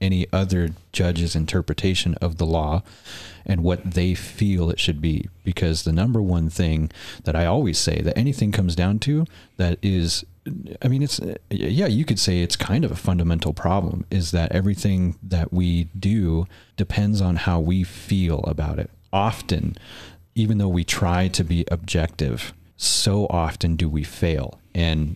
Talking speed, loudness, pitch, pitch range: 165 wpm, -22 LUFS, 90 Hz, 85-100 Hz